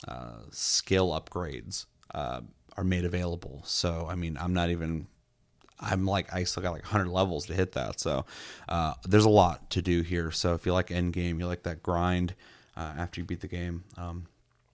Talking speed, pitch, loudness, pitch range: 200 wpm, 90 Hz, -30 LUFS, 85-90 Hz